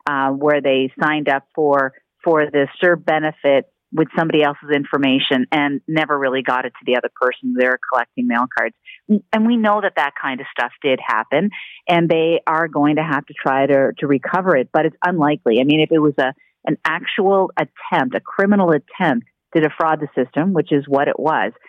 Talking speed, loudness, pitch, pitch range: 200 wpm, -18 LUFS, 150 Hz, 135-170 Hz